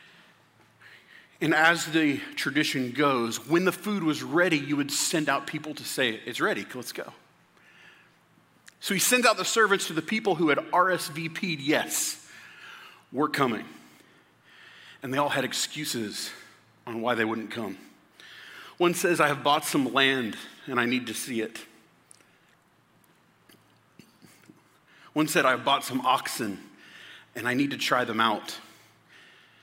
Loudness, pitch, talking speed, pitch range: -26 LUFS, 150 Hz, 150 wpm, 125-175 Hz